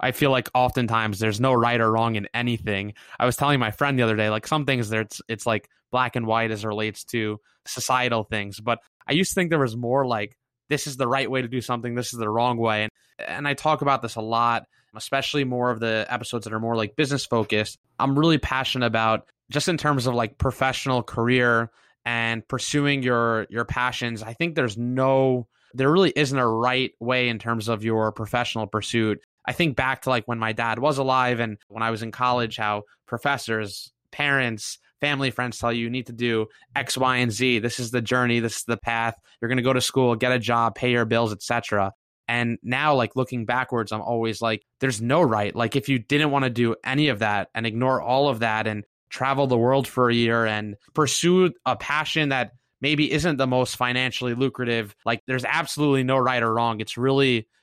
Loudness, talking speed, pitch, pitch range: -23 LUFS, 220 wpm, 120 Hz, 115-130 Hz